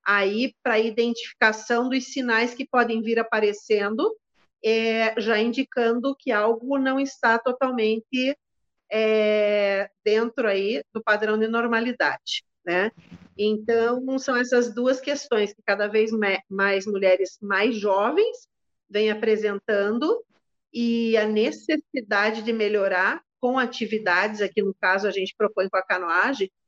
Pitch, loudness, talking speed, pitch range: 225 Hz, -23 LUFS, 125 wpm, 210-250 Hz